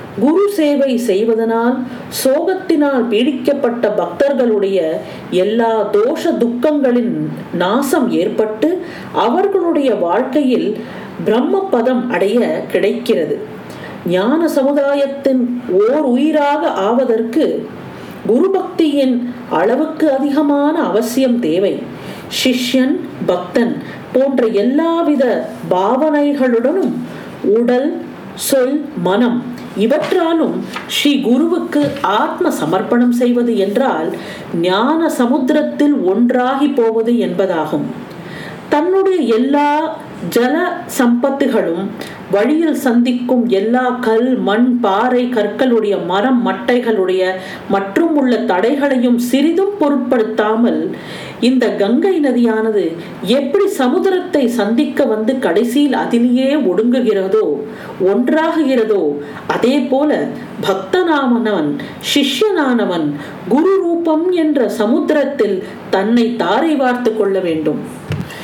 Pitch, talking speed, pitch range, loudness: 255 Hz, 75 wpm, 225-295 Hz, -15 LUFS